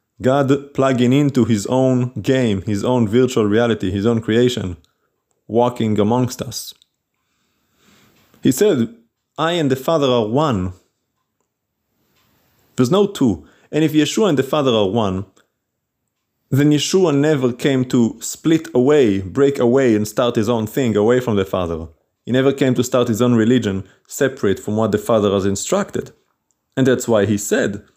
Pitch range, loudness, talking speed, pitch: 105-130 Hz, -17 LUFS, 155 wpm, 120 Hz